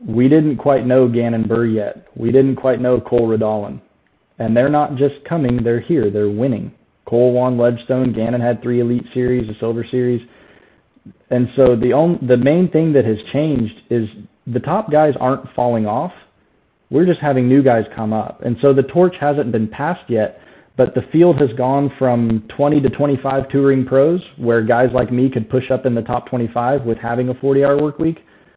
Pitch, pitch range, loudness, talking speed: 125 Hz, 120-140 Hz, -16 LUFS, 195 wpm